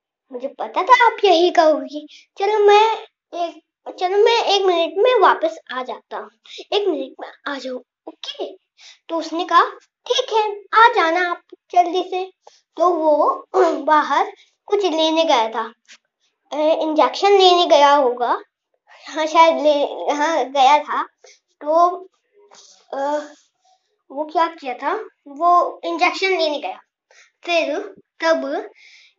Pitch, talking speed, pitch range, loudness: 345 Hz, 130 wpm, 305-395 Hz, -17 LUFS